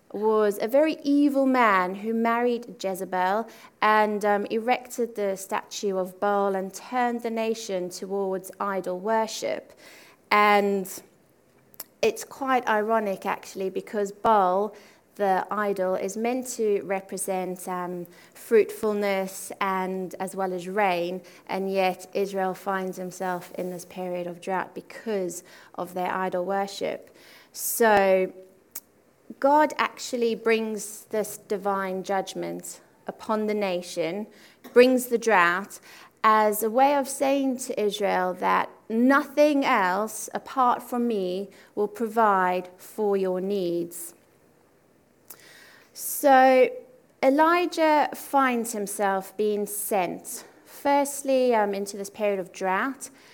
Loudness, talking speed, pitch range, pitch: -25 LUFS, 115 wpm, 190-235 Hz, 205 Hz